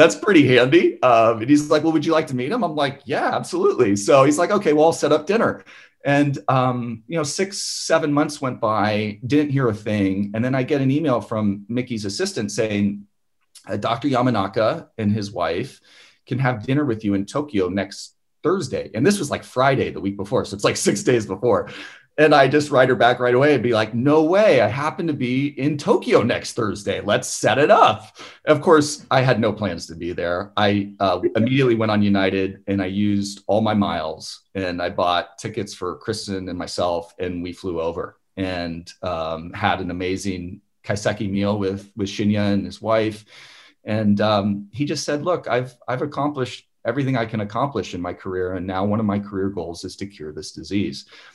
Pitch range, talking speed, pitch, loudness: 100-140 Hz, 210 wpm, 110 Hz, -20 LUFS